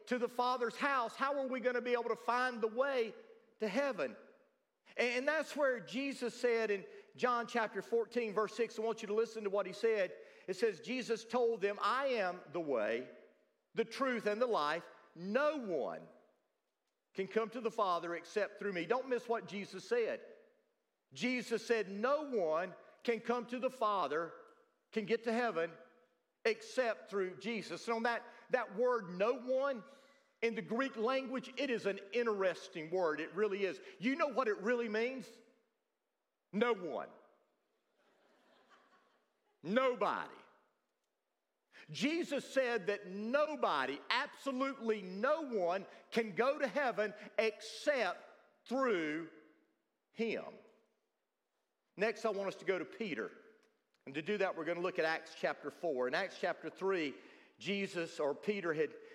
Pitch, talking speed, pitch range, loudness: 230 Hz, 155 wpm, 200-260 Hz, -37 LUFS